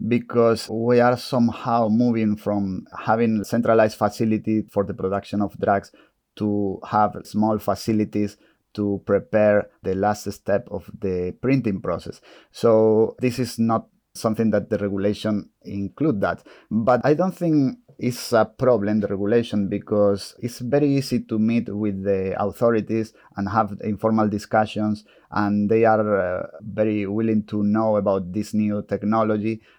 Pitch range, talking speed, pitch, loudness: 100-115 Hz, 140 wpm, 105 Hz, -22 LUFS